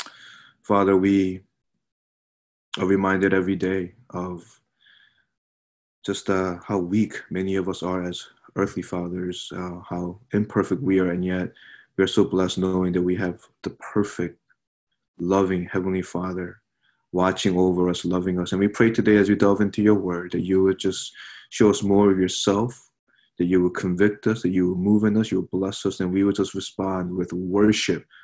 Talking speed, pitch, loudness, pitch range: 180 wpm, 95 Hz, -23 LUFS, 90-100 Hz